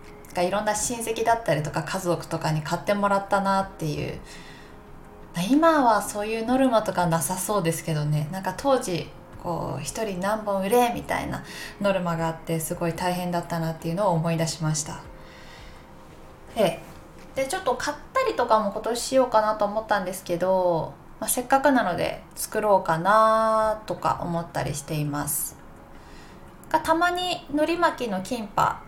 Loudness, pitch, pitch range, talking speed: -25 LUFS, 195 Hz, 165-225 Hz, 330 characters per minute